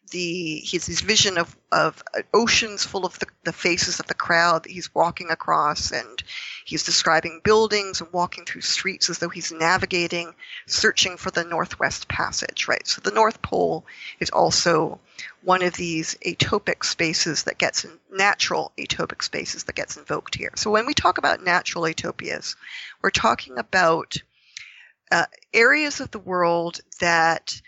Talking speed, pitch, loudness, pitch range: 160 wpm, 175 Hz, -22 LUFS, 165-185 Hz